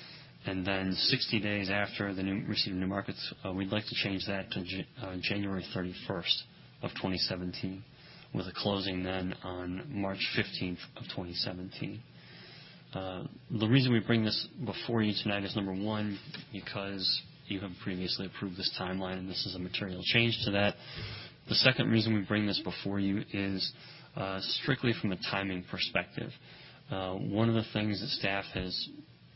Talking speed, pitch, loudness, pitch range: 170 wpm, 100 Hz, -33 LUFS, 95-110 Hz